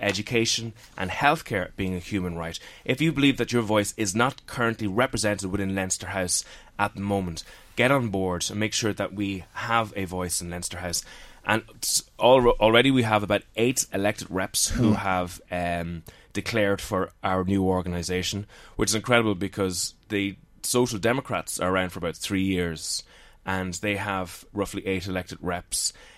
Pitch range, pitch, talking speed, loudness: 90-110 Hz, 100 Hz, 170 wpm, -25 LUFS